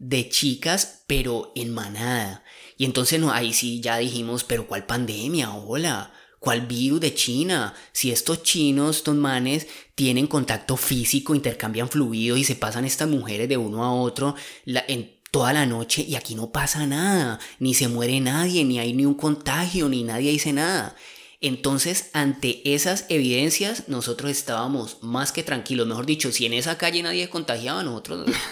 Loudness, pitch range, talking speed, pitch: -23 LUFS, 120-150 Hz, 170 wpm, 135 Hz